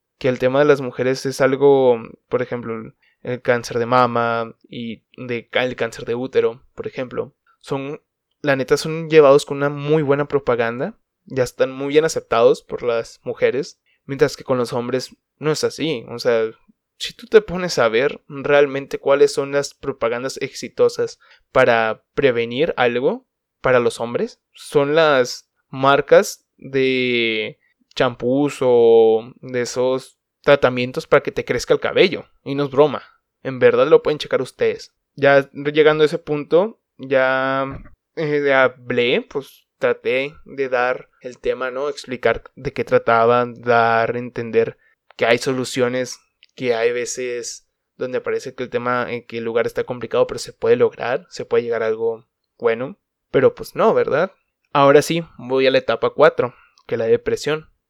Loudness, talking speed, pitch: -19 LUFS, 160 wpm, 145 Hz